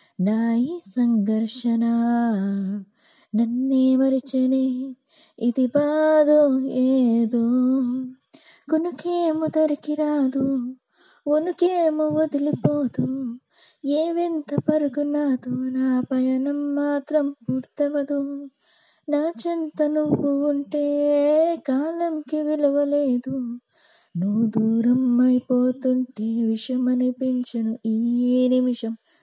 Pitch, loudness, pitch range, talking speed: 265 Hz, -22 LUFS, 245-300 Hz, 60 wpm